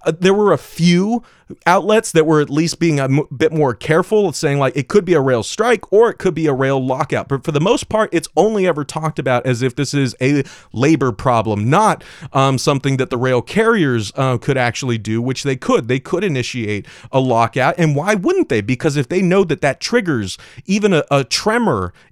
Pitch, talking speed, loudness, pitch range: 145 Hz, 225 wpm, -16 LUFS, 130-175 Hz